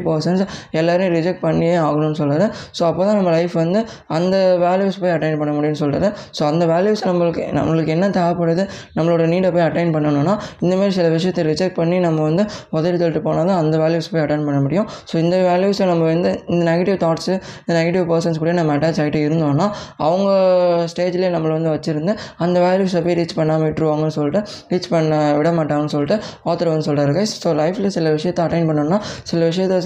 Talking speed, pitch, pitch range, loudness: 180 wpm, 170 Hz, 155-185 Hz, -18 LUFS